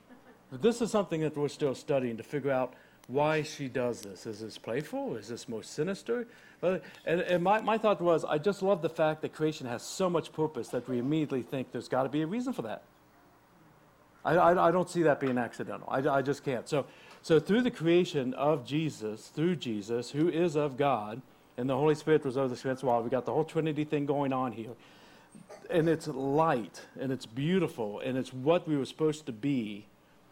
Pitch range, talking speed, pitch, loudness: 130-165 Hz, 210 wpm, 150 Hz, -31 LUFS